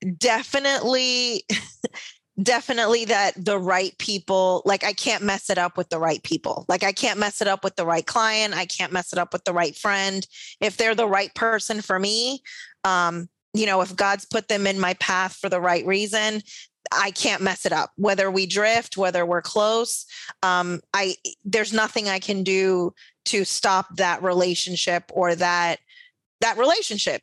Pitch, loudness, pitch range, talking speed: 195 Hz, -22 LUFS, 180-220 Hz, 180 wpm